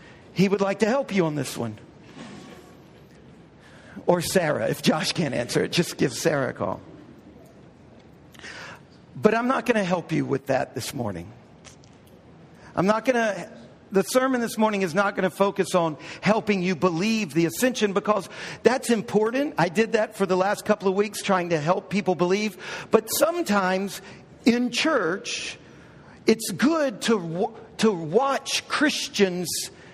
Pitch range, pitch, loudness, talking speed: 180-225 Hz, 205 Hz, -24 LUFS, 150 wpm